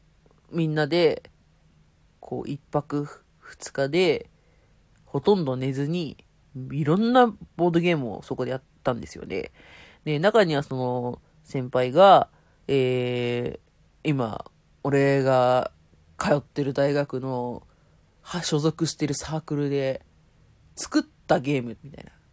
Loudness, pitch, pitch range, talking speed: -25 LUFS, 140 Hz, 130-160 Hz, 220 characters per minute